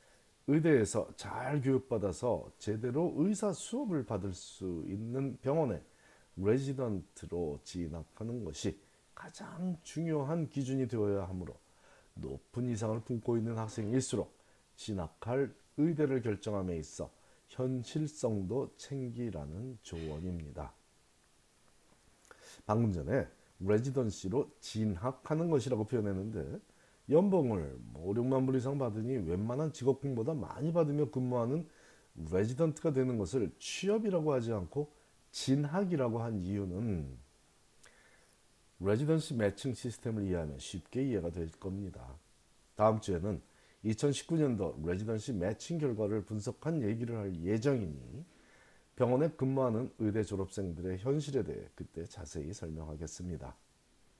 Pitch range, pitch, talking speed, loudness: 95-135 Hz, 115 Hz, 275 characters per minute, -35 LUFS